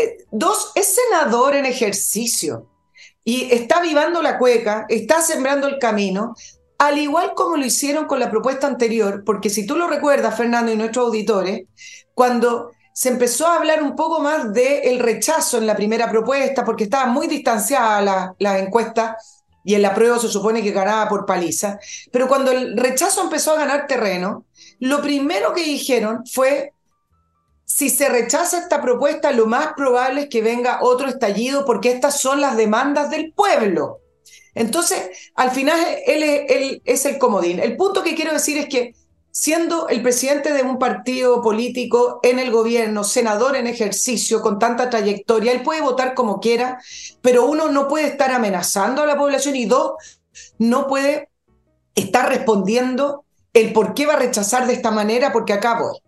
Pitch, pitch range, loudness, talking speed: 250 Hz, 225-285 Hz, -18 LUFS, 170 wpm